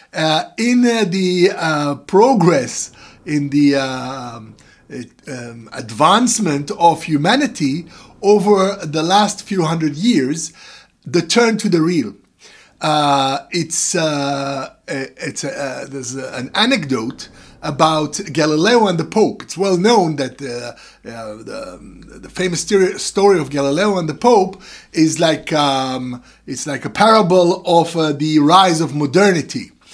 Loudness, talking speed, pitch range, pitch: -16 LUFS, 140 wpm, 140-190 Hz, 160 Hz